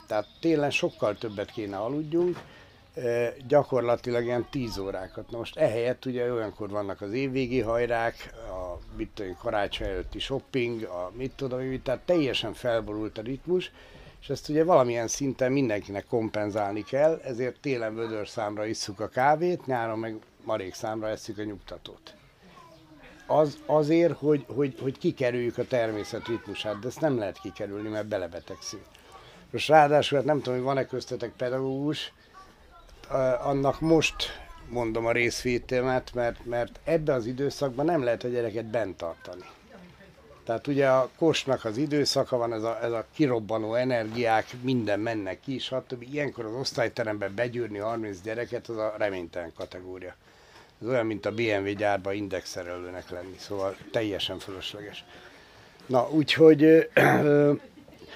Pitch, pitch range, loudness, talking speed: 120 Hz, 110-135 Hz, -28 LUFS, 140 wpm